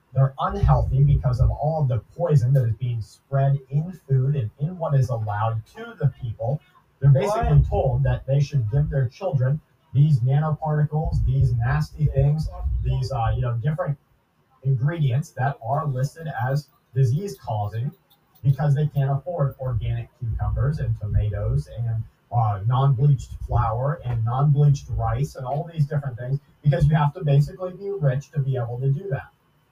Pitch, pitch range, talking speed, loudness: 135 Hz, 125-145 Hz, 160 wpm, -23 LUFS